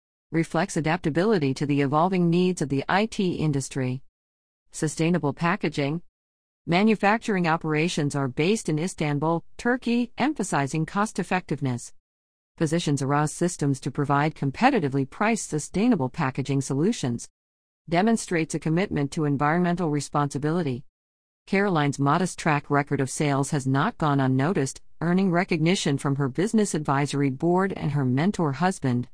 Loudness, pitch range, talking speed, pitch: -25 LUFS, 140-175 Hz, 120 wpm, 155 Hz